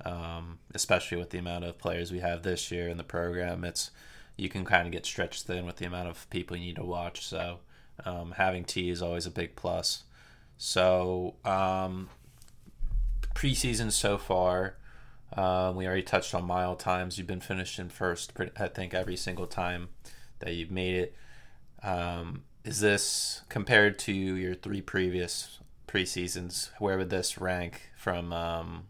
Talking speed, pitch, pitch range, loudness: 170 wpm, 90 Hz, 85-95 Hz, -32 LUFS